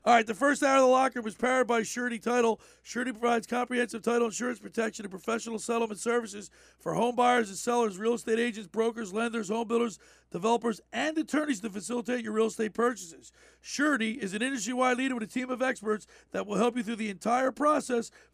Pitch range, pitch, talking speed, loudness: 225-250 Hz, 235 Hz, 205 wpm, -29 LUFS